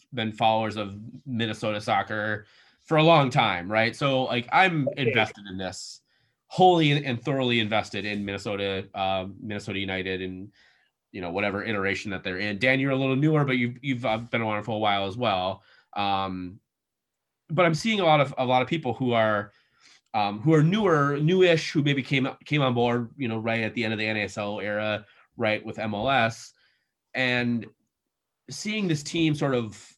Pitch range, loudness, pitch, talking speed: 105-135 Hz, -25 LUFS, 115 Hz, 185 wpm